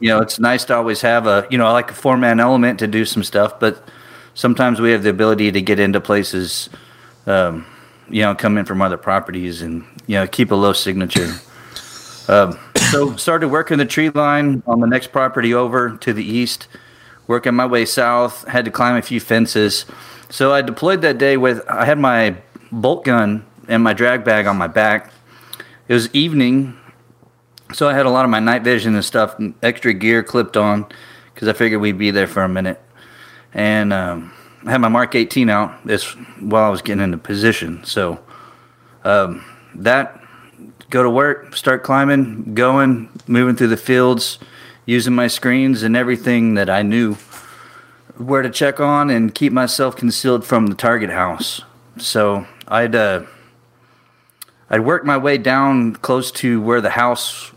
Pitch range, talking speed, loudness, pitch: 105-125 Hz, 185 wpm, -16 LUFS, 120 Hz